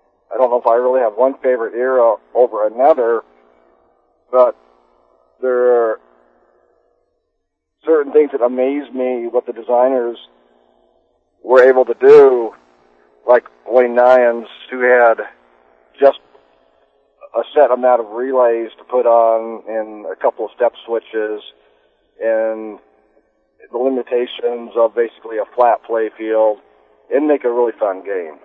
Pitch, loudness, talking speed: 115 Hz, -15 LUFS, 130 wpm